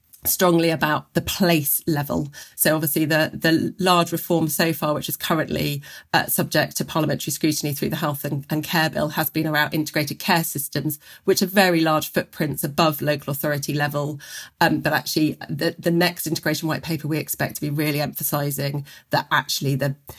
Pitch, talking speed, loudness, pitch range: 155 Hz, 180 wpm, -22 LUFS, 150-165 Hz